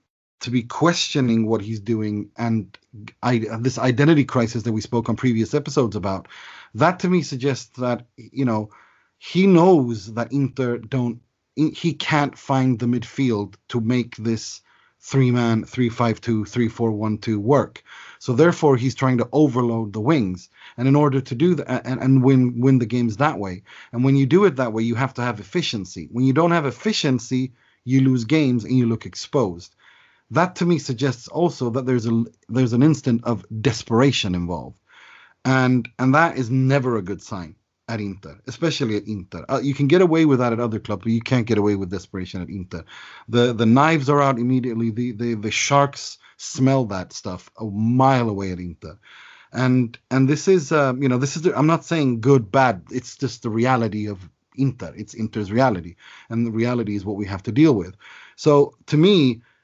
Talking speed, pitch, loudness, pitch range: 195 wpm, 125 Hz, -20 LUFS, 110-135 Hz